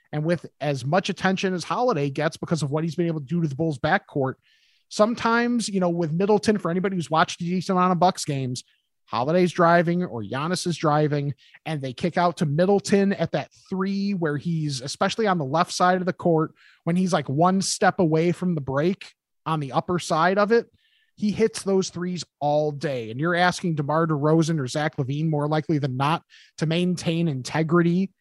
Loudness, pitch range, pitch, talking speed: -23 LUFS, 155-185 Hz, 170 Hz, 205 wpm